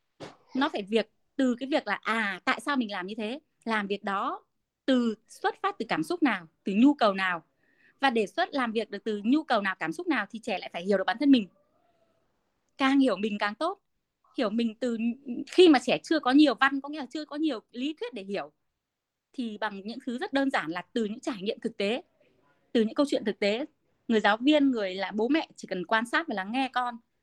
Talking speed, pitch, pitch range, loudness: 240 wpm, 245 Hz, 210-285 Hz, -28 LUFS